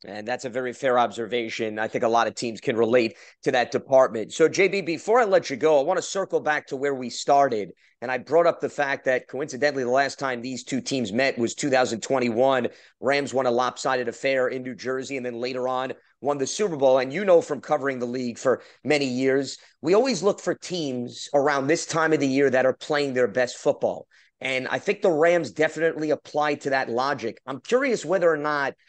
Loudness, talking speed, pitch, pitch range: -24 LUFS, 225 wpm, 135 Hz, 125-155 Hz